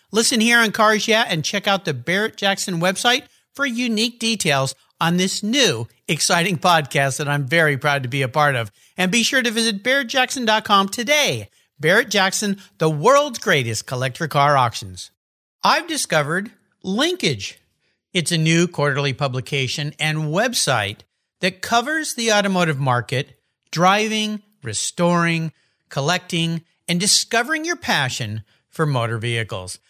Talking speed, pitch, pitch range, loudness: 140 wpm, 180 Hz, 145-220 Hz, -19 LUFS